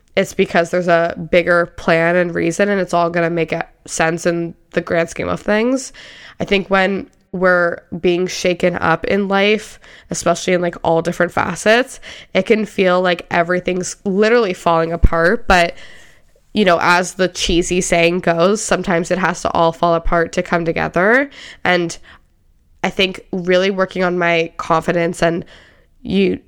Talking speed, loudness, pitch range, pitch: 165 wpm, -16 LUFS, 170-190 Hz, 180 Hz